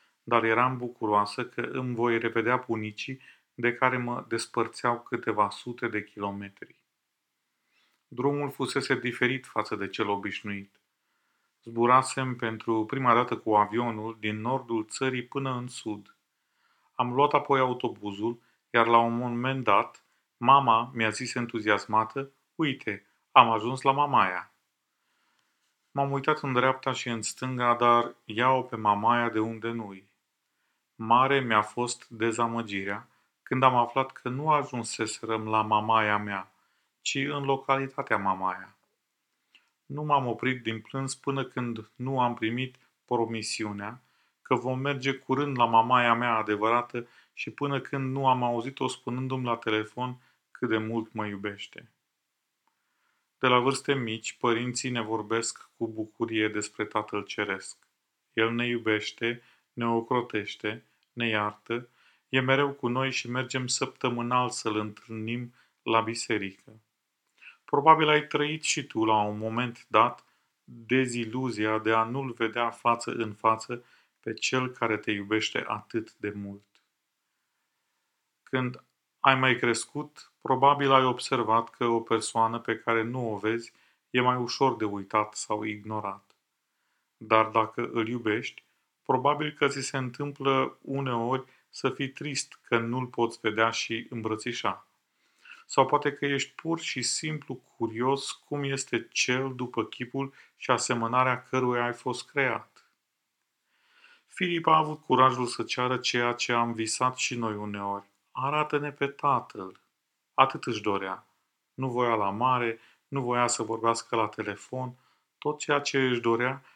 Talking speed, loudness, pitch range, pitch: 135 wpm, -28 LUFS, 110-130 Hz, 120 Hz